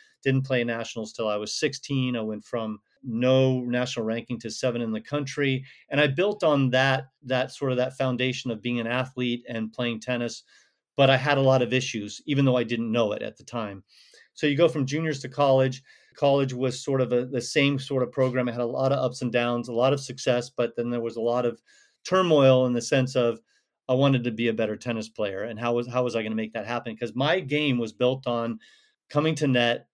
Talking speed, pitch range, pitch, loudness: 240 wpm, 120-135 Hz, 125 Hz, -25 LUFS